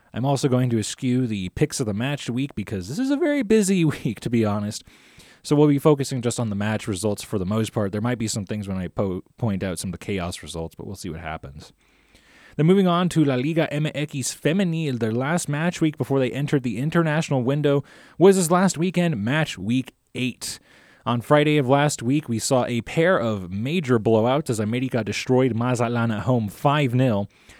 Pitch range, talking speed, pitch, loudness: 110-150 Hz, 215 wpm, 130 Hz, -22 LUFS